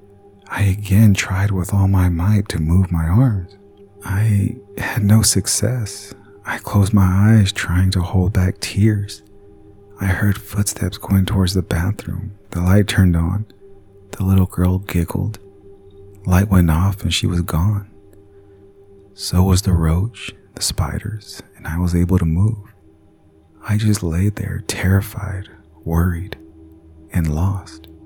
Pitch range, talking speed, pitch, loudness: 90-100 Hz, 140 wpm, 100 Hz, -18 LUFS